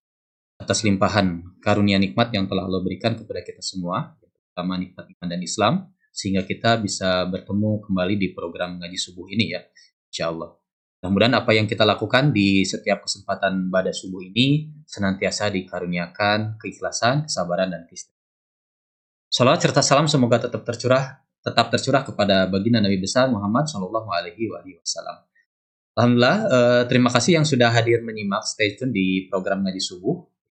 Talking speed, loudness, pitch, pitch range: 150 wpm, -21 LUFS, 100 Hz, 95-120 Hz